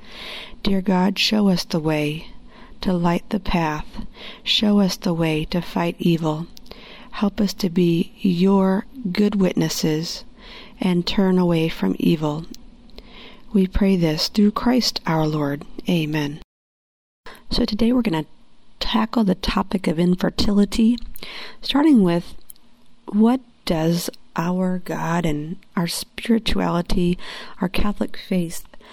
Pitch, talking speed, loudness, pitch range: 195 Hz, 120 wpm, -21 LUFS, 170-225 Hz